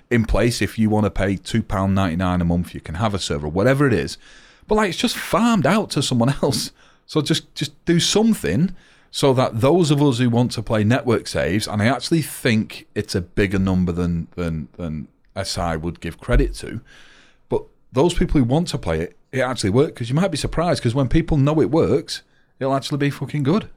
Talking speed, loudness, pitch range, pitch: 225 wpm, -20 LUFS, 95-150 Hz, 125 Hz